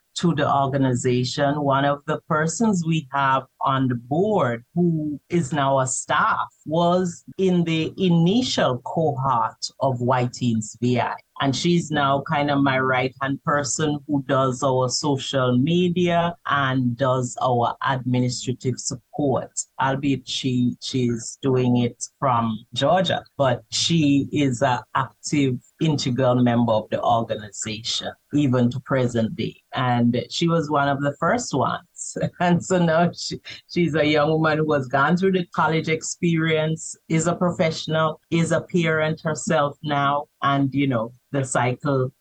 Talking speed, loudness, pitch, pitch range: 145 wpm, -22 LUFS, 140 Hz, 125-160 Hz